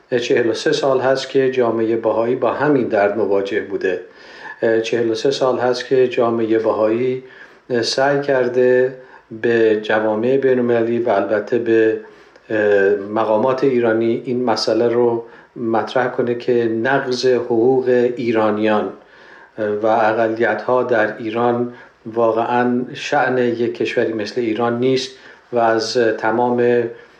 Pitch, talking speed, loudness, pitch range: 120 Hz, 115 wpm, -17 LUFS, 115-130 Hz